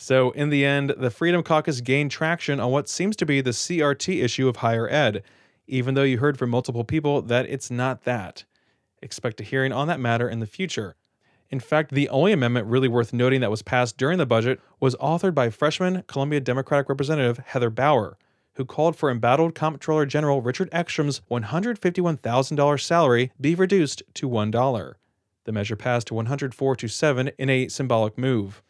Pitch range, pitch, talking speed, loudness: 120-150 Hz, 135 Hz, 185 wpm, -23 LUFS